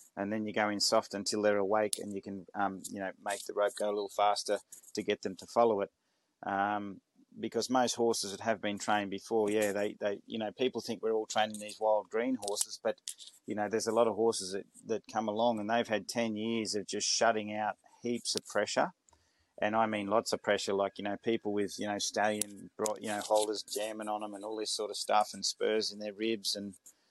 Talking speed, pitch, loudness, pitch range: 240 wpm, 105 Hz, -33 LUFS, 100-110 Hz